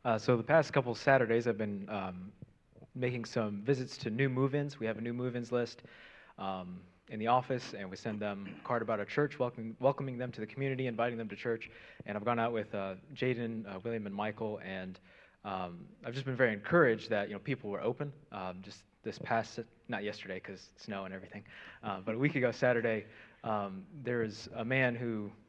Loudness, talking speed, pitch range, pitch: -35 LUFS, 210 wpm, 100-125 Hz, 115 Hz